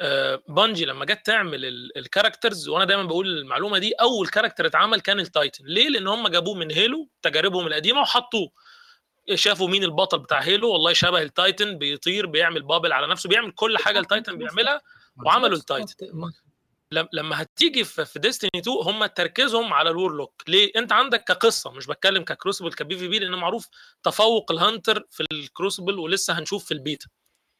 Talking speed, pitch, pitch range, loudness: 160 wpm, 195 Hz, 170-235 Hz, -21 LUFS